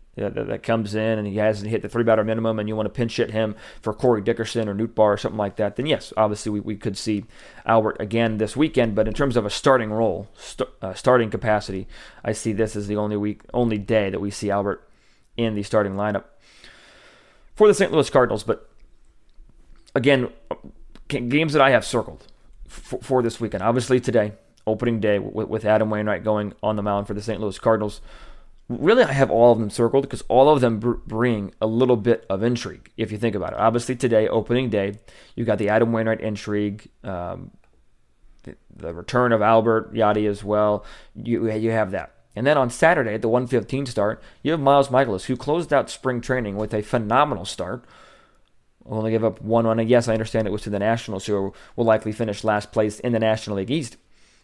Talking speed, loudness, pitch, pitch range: 215 wpm, -22 LUFS, 110 Hz, 105-120 Hz